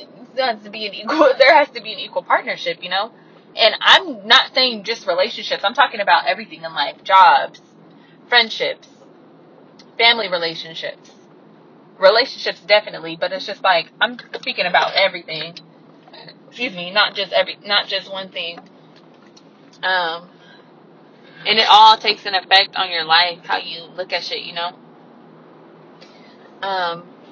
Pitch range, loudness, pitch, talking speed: 175-230 Hz, -16 LUFS, 195 Hz, 150 wpm